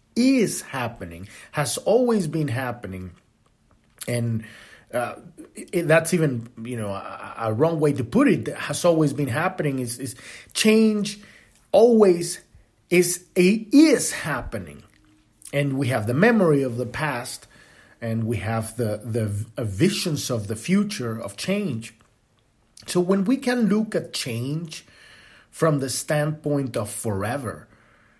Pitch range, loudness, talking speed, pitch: 115-175 Hz, -23 LUFS, 130 wpm, 135 Hz